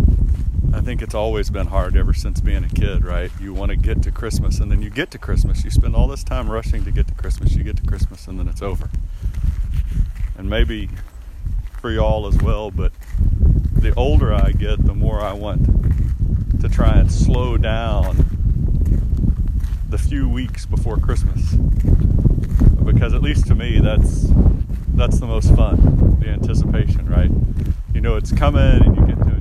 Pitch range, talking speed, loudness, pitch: 80-100 Hz, 180 wpm, -19 LUFS, 90 Hz